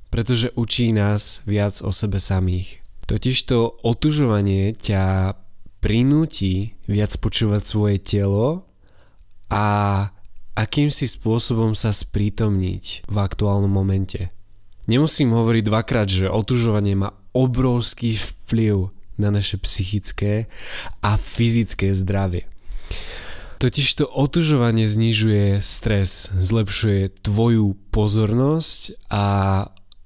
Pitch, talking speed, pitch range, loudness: 105 Hz, 95 wpm, 95-115 Hz, -19 LUFS